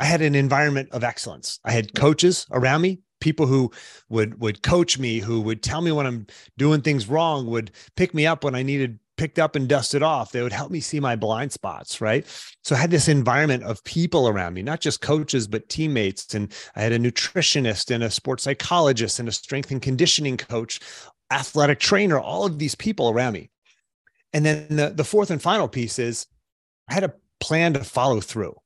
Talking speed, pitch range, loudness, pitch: 210 wpm, 115-155 Hz, -22 LUFS, 140 Hz